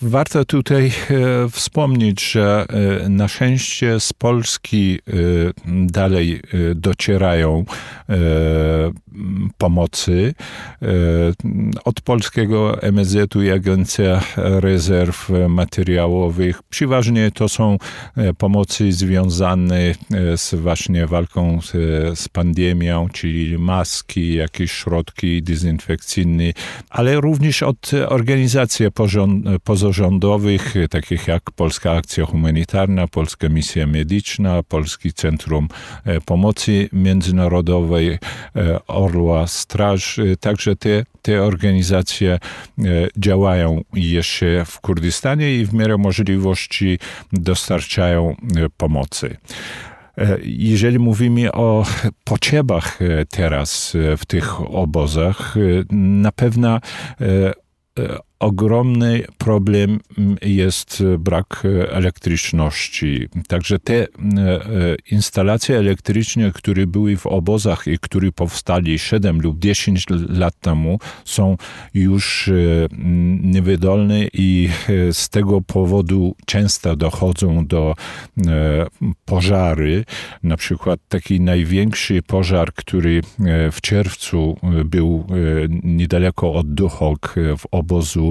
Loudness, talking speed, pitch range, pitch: -17 LUFS, 90 wpm, 85-105 Hz, 95 Hz